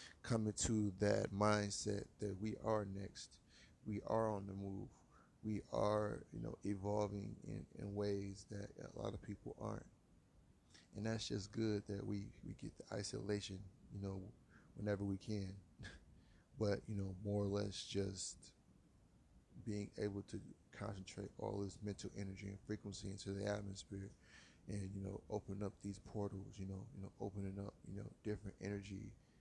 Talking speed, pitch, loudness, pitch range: 160 wpm, 100 Hz, -45 LUFS, 95-105 Hz